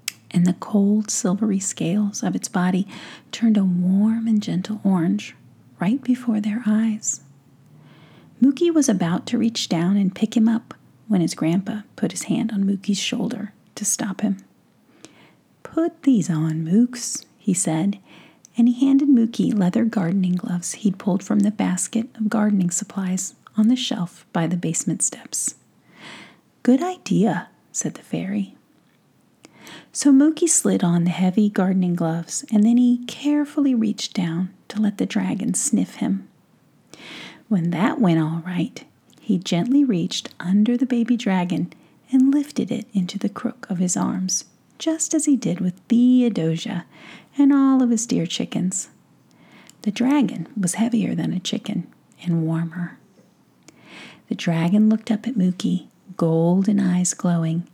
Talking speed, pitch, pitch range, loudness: 150 wpm, 210 Hz, 180-235 Hz, -21 LUFS